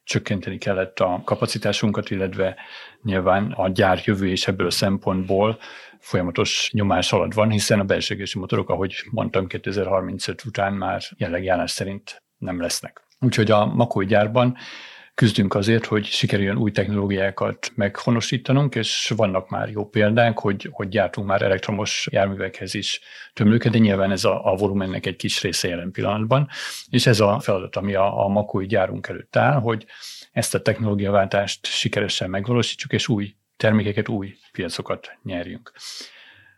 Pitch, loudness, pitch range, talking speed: 105 Hz, -22 LUFS, 95-115 Hz, 145 wpm